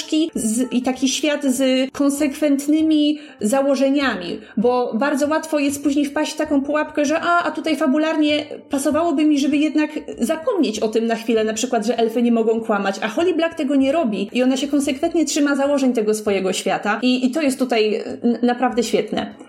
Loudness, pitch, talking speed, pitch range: -19 LUFS, 275 Hz, 185 wpm, 235-300 Hz